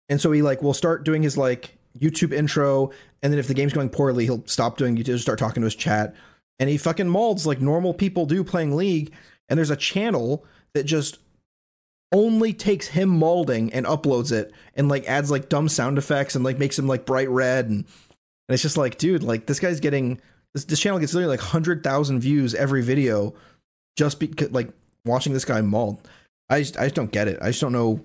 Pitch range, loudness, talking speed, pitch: 125-155 Hz, -22 LUFS, 220 wpm, 140 Hz